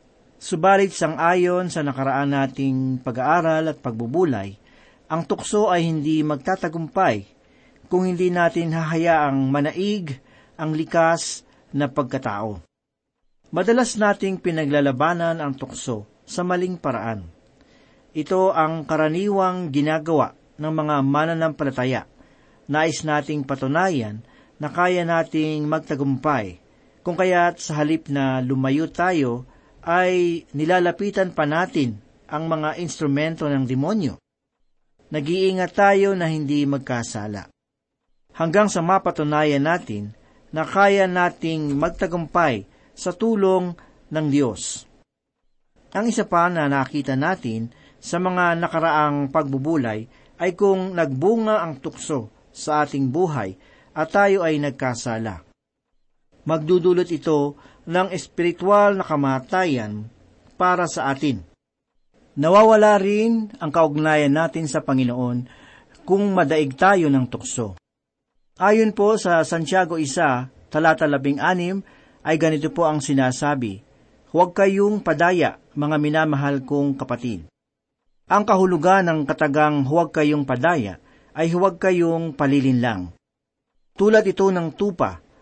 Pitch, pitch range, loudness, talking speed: 155 Hz, 135-180 Hz, -21 LUFS, 110 wpm